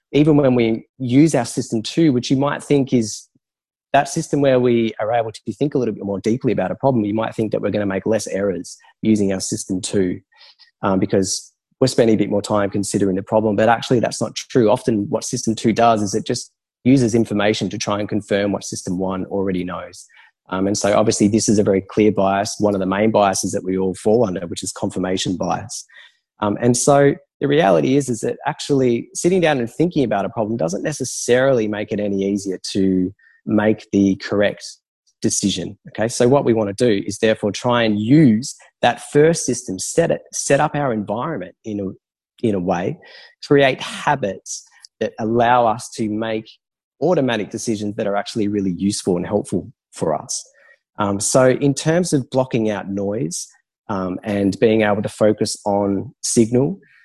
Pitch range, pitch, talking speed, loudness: 100-125 Hz, 110 Hz, 200 wpm, -19 LUFS